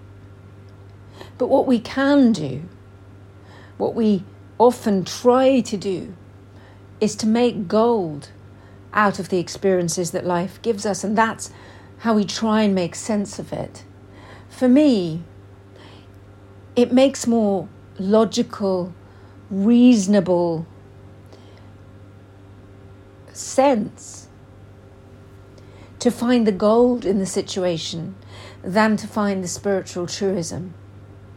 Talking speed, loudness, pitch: 105 wpm, -20 LUFS, 165 Hz